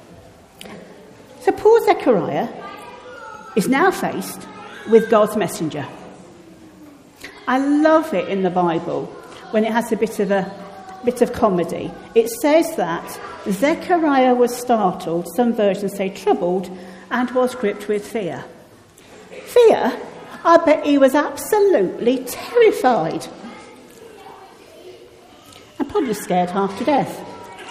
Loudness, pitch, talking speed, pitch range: -18 LUFS, 235 Hz, 115 wpm, 195-315 Hz